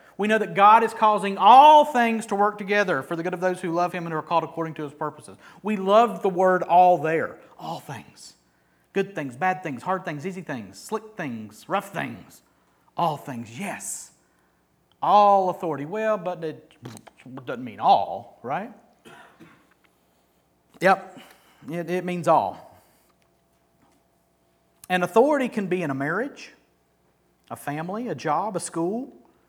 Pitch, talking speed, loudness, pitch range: 180 Hz, 155 wpm, -22 LUFS, 150-205 Hz